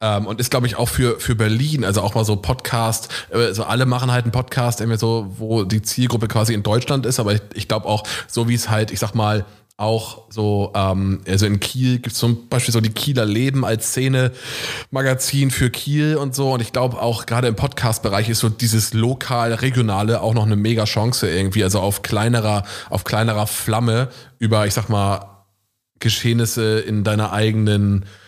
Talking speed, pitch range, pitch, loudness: 200 wpm, 105-125 Hz, 115 Hz, -19 LUFS